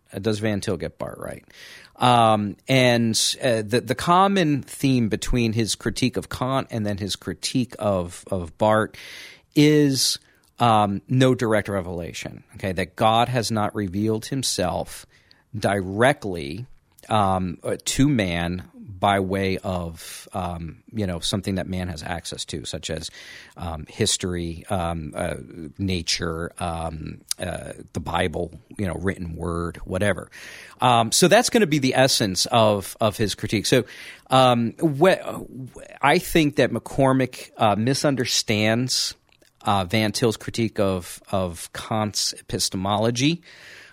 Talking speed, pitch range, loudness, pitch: 135 wpm, 95-125 Hz, -22 LUFS, 105 Hz